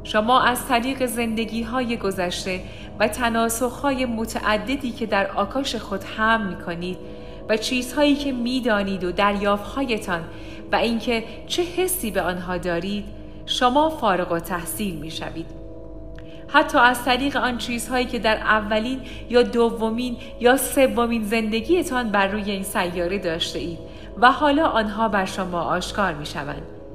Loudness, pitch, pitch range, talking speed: -22 LUFS, 225 Hz, 195-250 Hz, 145 wpm